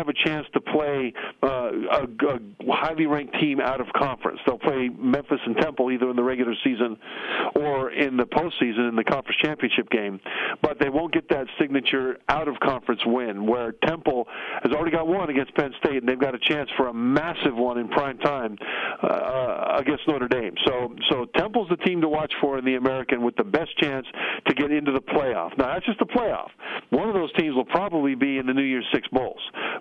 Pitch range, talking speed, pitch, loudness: 125-150 Hz, 215 wpm, 135 Hz, -24 LUFS